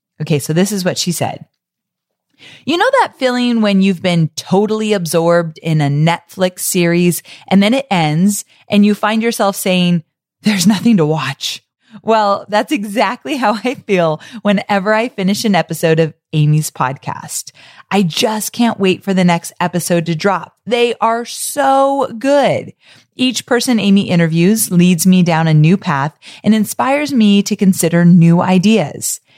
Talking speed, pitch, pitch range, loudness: 160 wpm, 195 Hz, 170-220 Hz, -14 LUFS